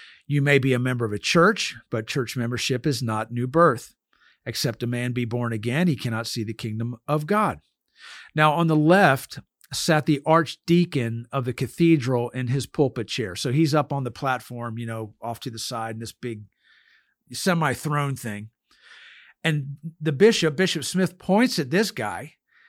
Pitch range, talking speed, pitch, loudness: 120-160 Hz, 180 wpm, 130 Hz, -23 LUFS